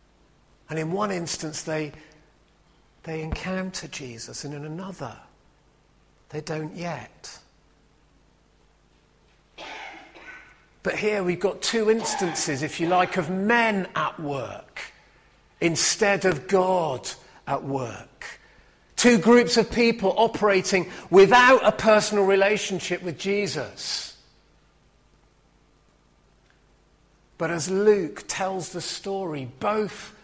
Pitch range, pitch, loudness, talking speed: 155-200 Hz, 180 Hz, -23 LUFS, 100 wpm